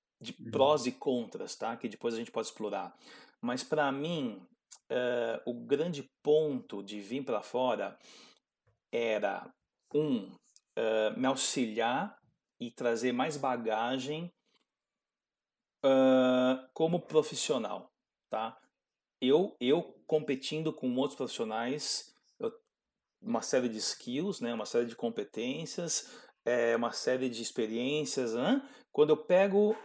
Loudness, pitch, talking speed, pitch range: -32 LUFS, 135 Hz, 120 wpm, 120-155 Hz